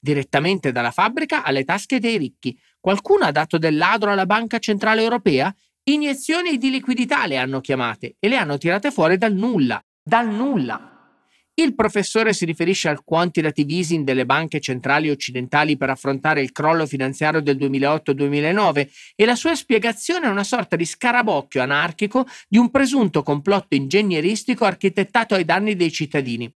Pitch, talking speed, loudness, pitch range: 175 Hz, 155 wpm, -19 LUFS, 145-225 Hz